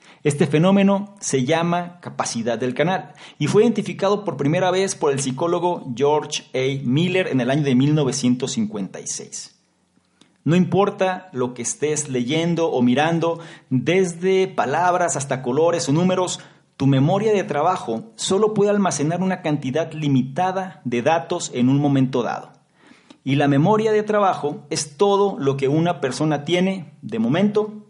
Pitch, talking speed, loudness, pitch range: 165 Hz, 145 wpm, -20 LUFS, 140-185 Hz